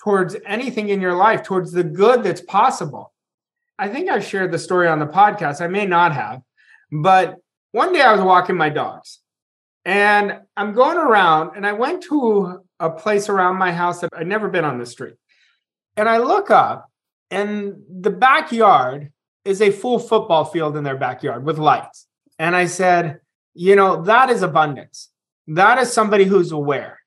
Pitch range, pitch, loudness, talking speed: 165-210 Hz, 185 Hz, -17 LUFS, 180 wpm